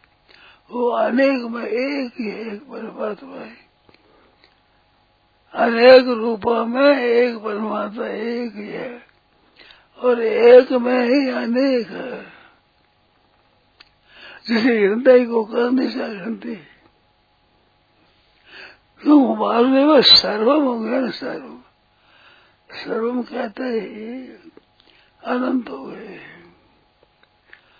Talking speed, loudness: 80 wpm, -17 LUFS